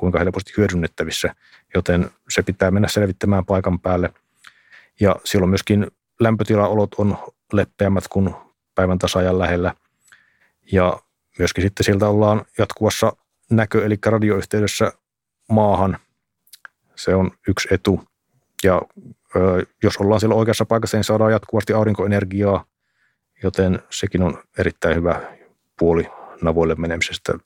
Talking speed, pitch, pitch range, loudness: 115 wpm, 100 Hz, 90-105 Hz, -19 LUFS